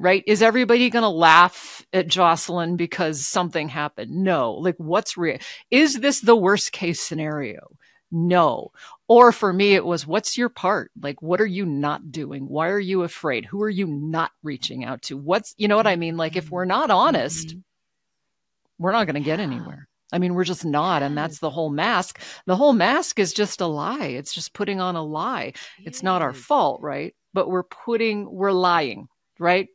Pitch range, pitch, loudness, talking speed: 160-205 Hz, 180 Hz, -21 LUFS, 200 wpm